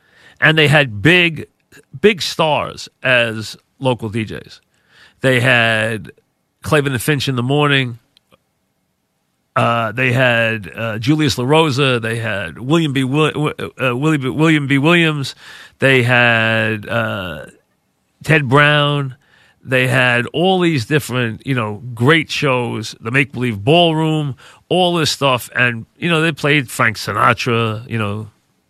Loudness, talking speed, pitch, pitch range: -15 LUFS, 130 wpm, 130 Hz, 115-150 Hz